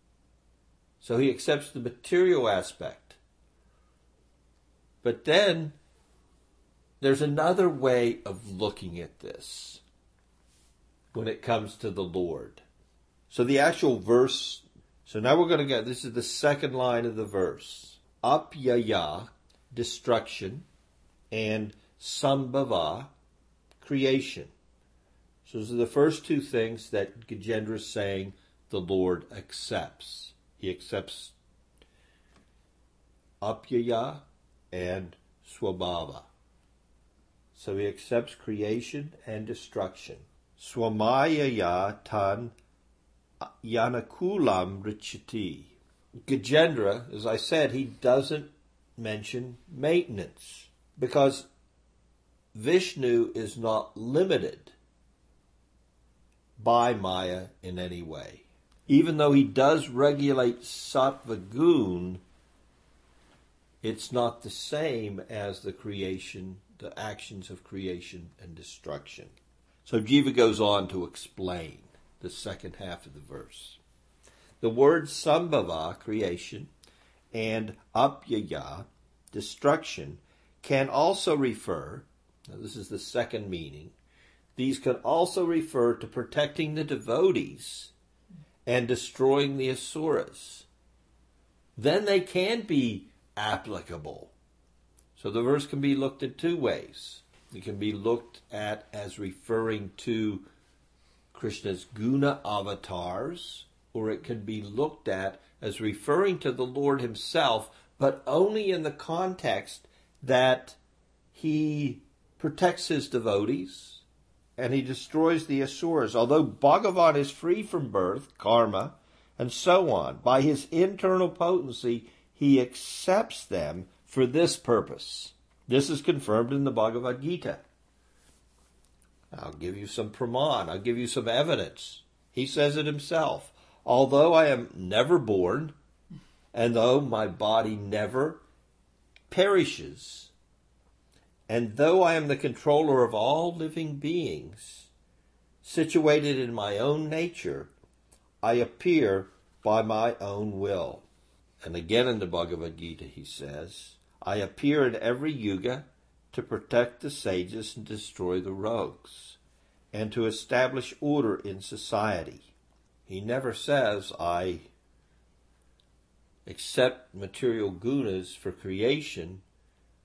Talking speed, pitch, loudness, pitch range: 110 wpm, 110 Hz, -28 LUFS, 80-135 Hz